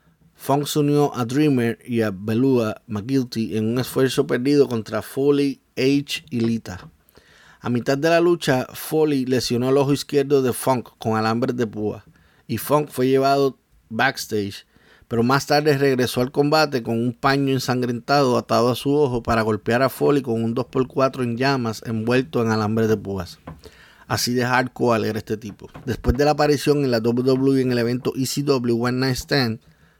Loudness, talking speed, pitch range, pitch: -21 LUFS, 175 wpm, 115-140 Hz, 125 Hz